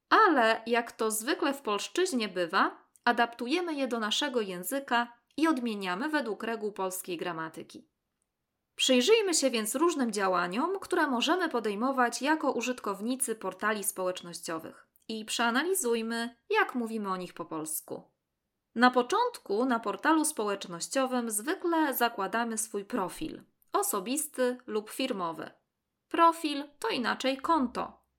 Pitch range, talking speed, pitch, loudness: 205-290 Hz, 115 wpm, 235 Hz, -30 LUFS